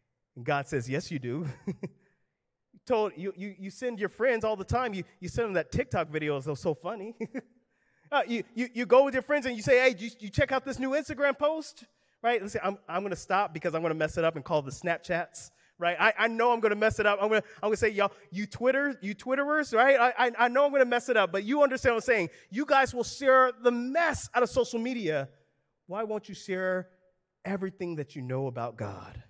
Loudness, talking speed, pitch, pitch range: -28 LUFS, 240 wpm, 210 Hz, 175-250 Hz